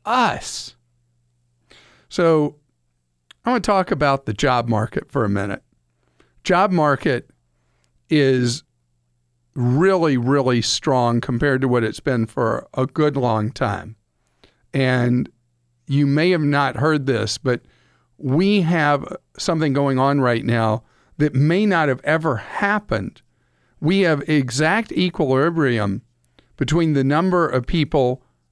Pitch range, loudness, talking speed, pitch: 110-155 Hz, -19 LUFS, 125 wpm, 130 Hz